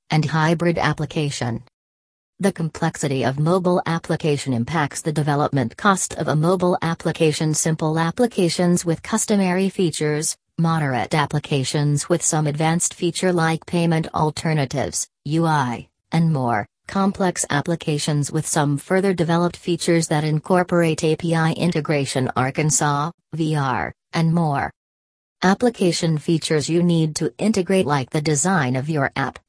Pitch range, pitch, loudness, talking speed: 145-170 Hz, 160 Hz, -20 LUFS, 120 wpm